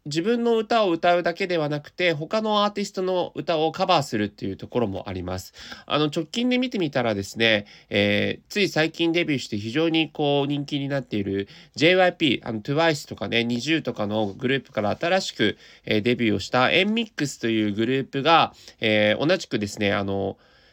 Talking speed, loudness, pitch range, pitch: 400 characters per minute, -23 LUFS, 110-170 Hz, 140 Hz